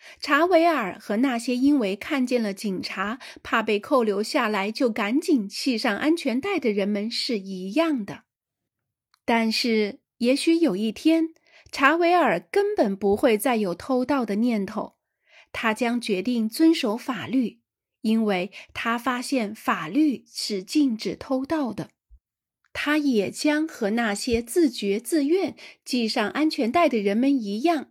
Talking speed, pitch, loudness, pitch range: 205 characters per minute, 245 Hz, -24 LUFS, 210-295 Hz